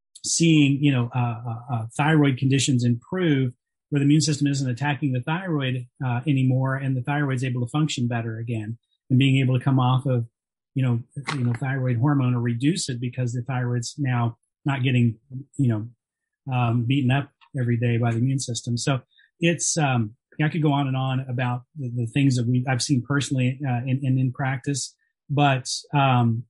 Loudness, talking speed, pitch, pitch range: -23 LUFS, 190 wpm, 130 Hz, 120-140 Hz